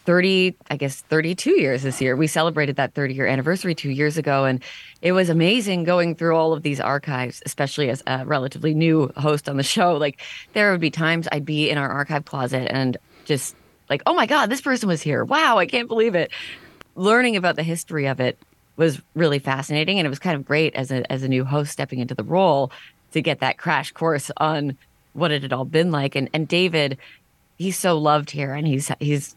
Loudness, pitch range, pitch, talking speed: -21 LUFS, 135-170 Hz, 150 Hz, 220 wpm